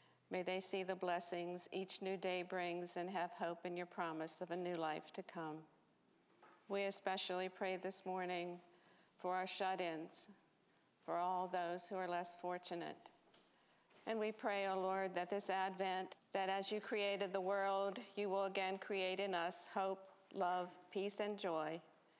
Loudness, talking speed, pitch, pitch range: -43 LUFS, 170 wpm, 185 Hz, 175-195 Hz